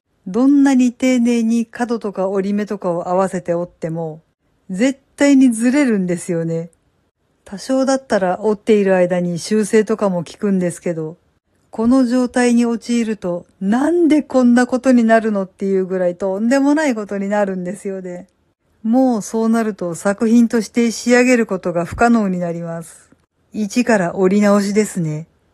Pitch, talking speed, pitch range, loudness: 210 Hz, 330 characters per minute, 180-240 Hz, -16 LUFS